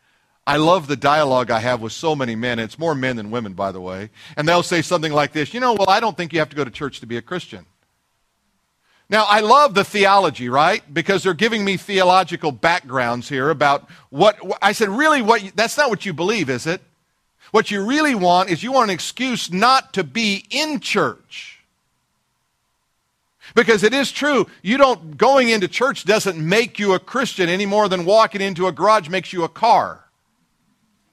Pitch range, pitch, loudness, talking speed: 150-215 Hz, 185 Hz, -18 LUFS, 200 wpm